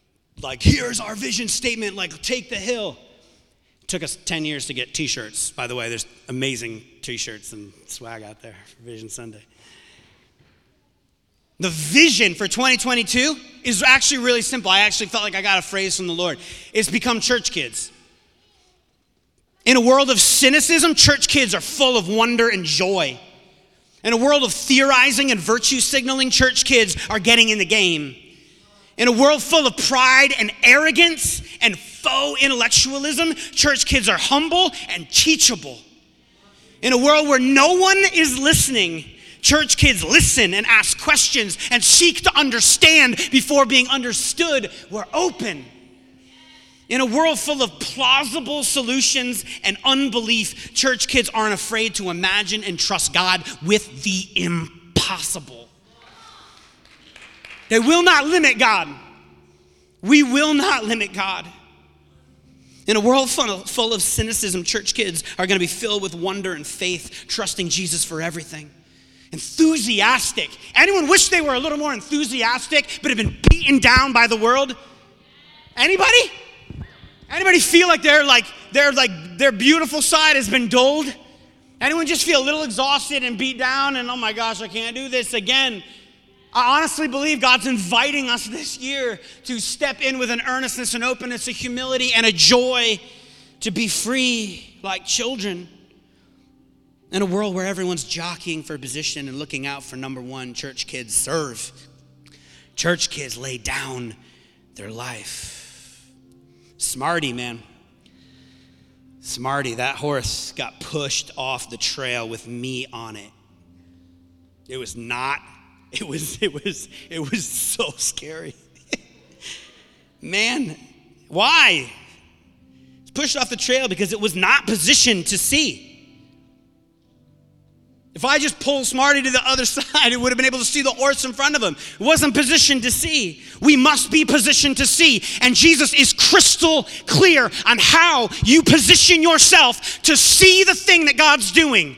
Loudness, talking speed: -16 LUFS, 155 wpm